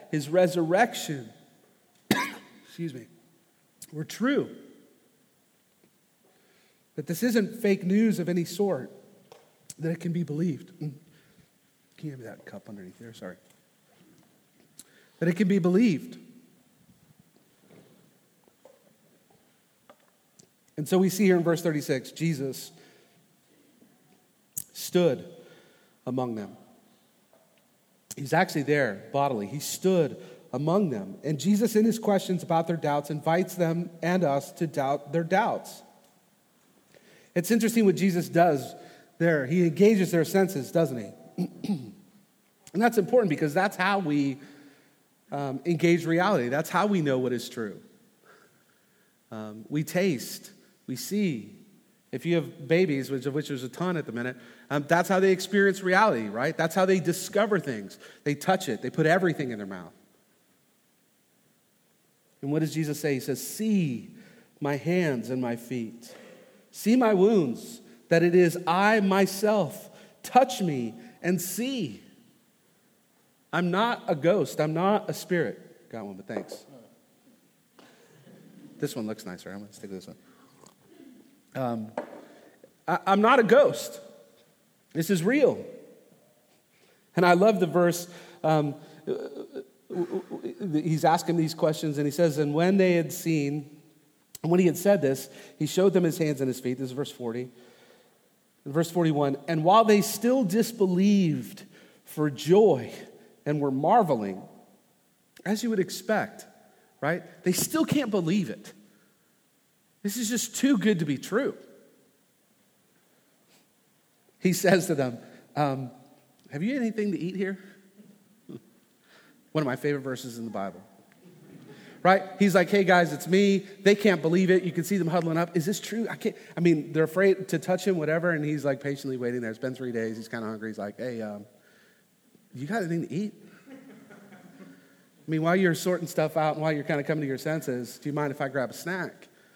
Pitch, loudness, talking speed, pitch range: 170 Hz, -26 LUFS, 155 wpm, 145-195 Hz